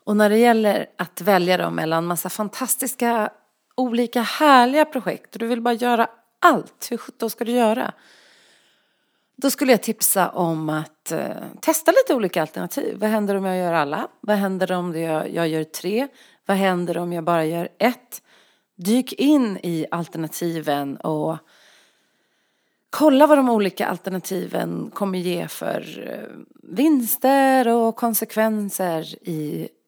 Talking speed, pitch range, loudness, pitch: 150 wpm, 175-245 Hz, -21 LUFS, 210 Hz